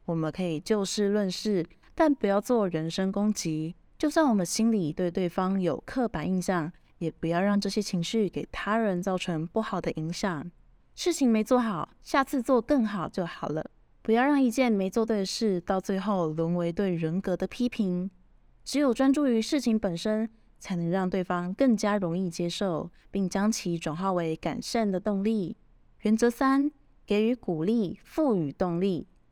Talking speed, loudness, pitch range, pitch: 255 characters per minute, -28 LUFS, 175-225 Hz, 195 Hz